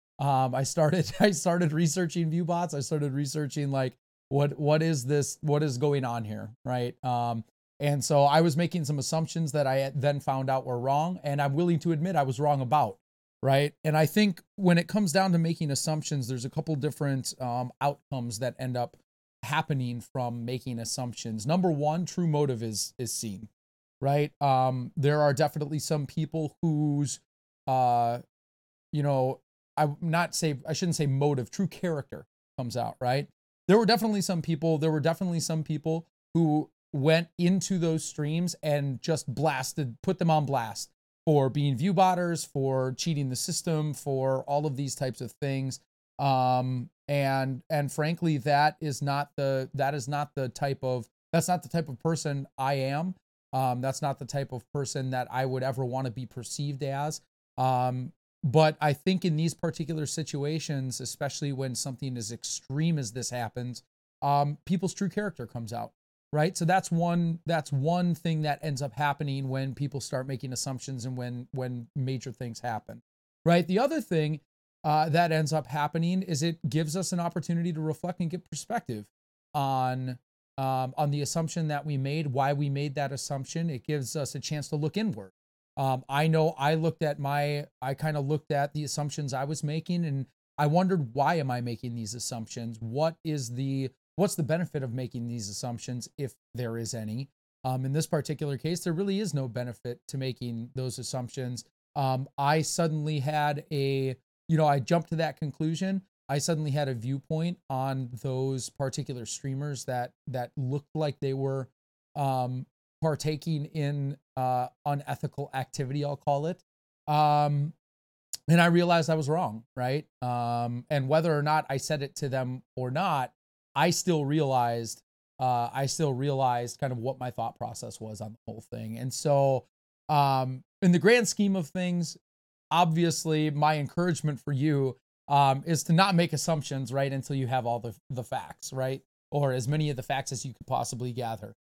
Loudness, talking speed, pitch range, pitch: -29 LUFS, 180 wpm, 130-160 Hz, 145 Hz